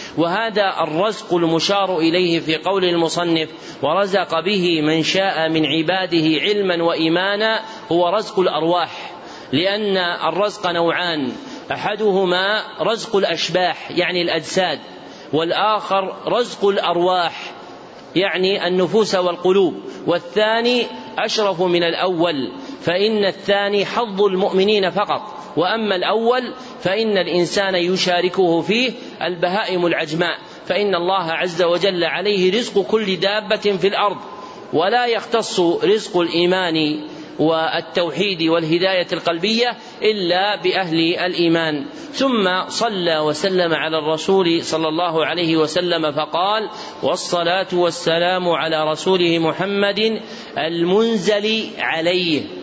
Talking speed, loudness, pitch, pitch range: 100 wpm, -18 LUFS, 185 Hz, 170-205 Hz